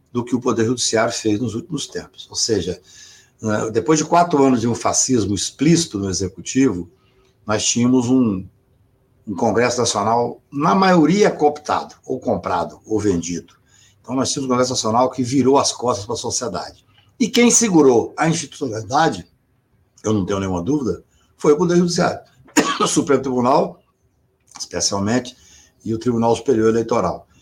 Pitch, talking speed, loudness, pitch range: 125 Hz, 155 wpm, -18 LUFS, 105-140 Hz